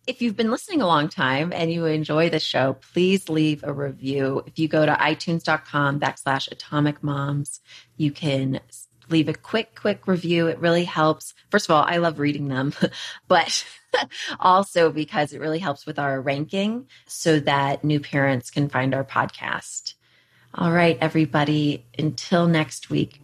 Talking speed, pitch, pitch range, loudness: 165 wpm, 150 Hz, 140-170 Hz, -22 LUFS